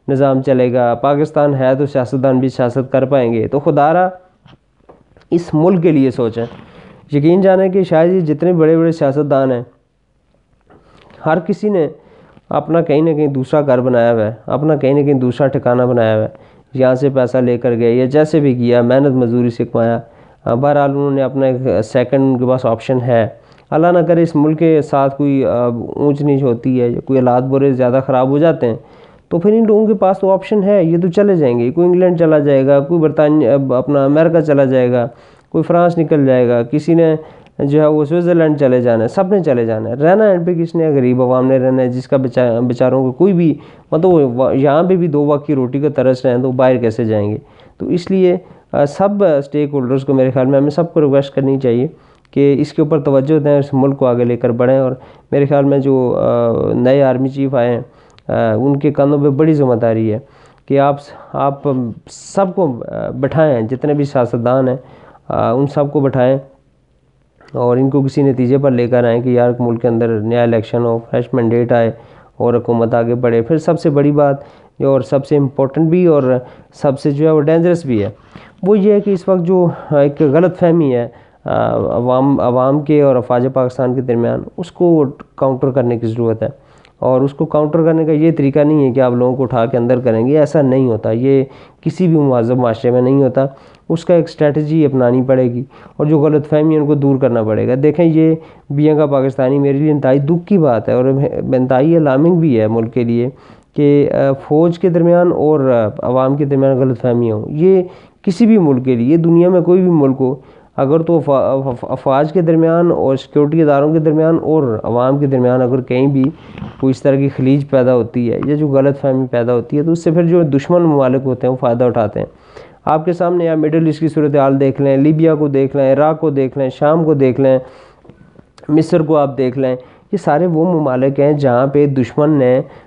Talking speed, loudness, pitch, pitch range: 215 wpm, -13 LUFS, 140 Hz, 125-155 Hz